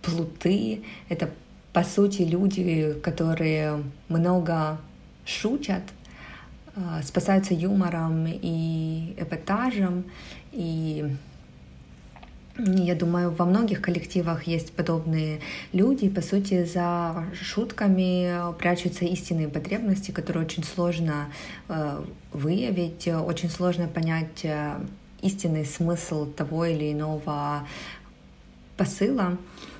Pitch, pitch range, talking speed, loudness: 170 Hz, 155-180 Hz, 85 wpm, -27 LUFS